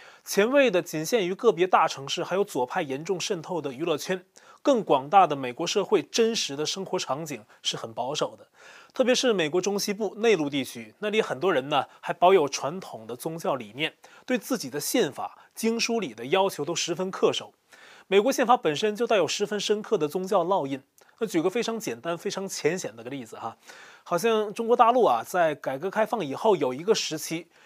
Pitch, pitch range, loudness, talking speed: 190 Hz, 165-220 Hz, -26 LUFS, 305 characters per minute